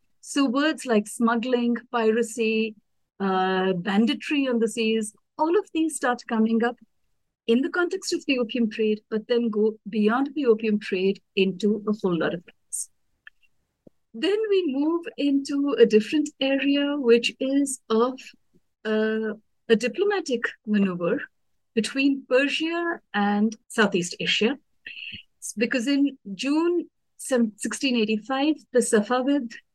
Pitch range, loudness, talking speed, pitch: 220-280 Hz, -24 LUFS, 125 wpm, 235 Hz